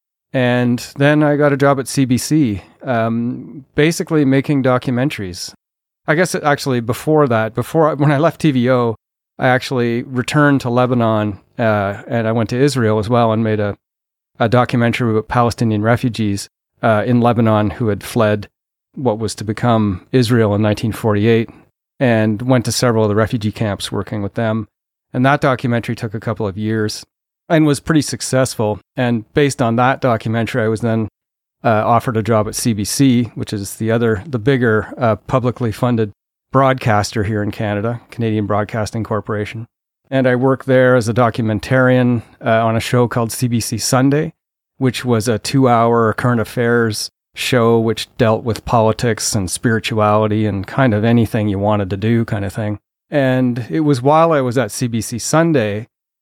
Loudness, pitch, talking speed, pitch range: -16 LUFS, 115 Hz, 170 wpm, 110-130 Hz